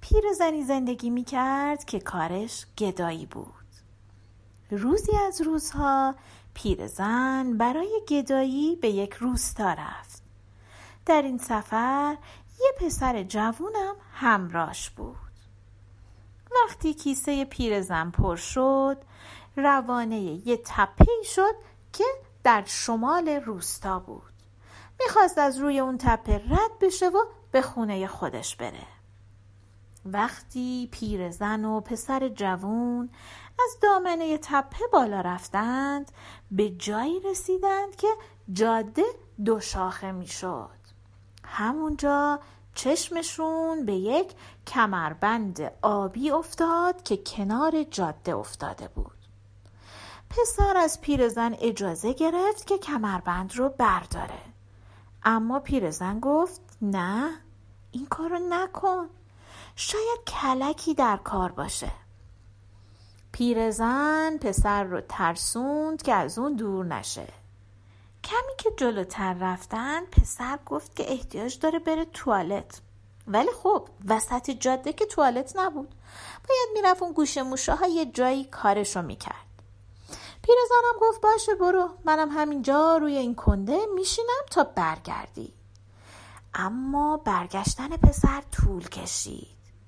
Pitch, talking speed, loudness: 240 Hz, 105 wpm, -26 LUFS